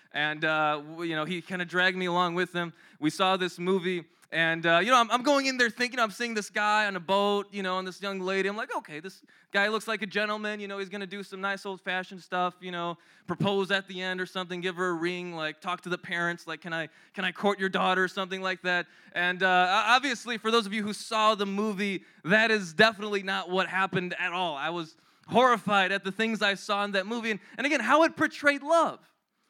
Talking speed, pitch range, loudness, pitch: 255 wpm, 180-210 Hz, -27 LUFS, 190 Hz